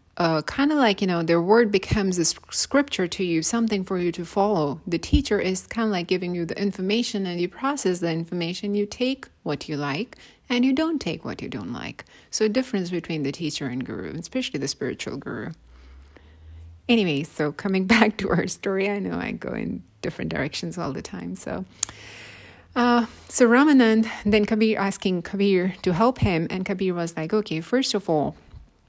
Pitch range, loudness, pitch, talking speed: 165-220 Hz, -24 LUFS, 190 Hz, 195 wpm